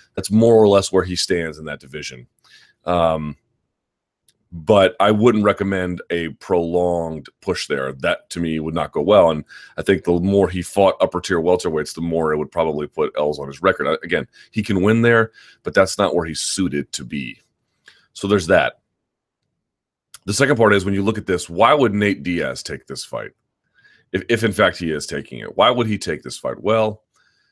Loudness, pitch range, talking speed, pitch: -19 LUFS, 80-100 Hz, 205 wpm, 90 Hz